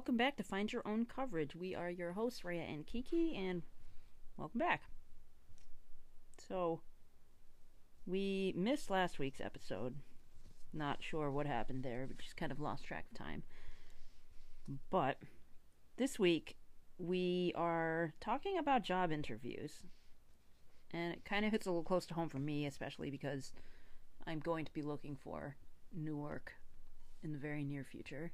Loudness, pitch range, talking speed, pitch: -42 LUFS, 115-180 Hz, 150 wpm, 150 Hz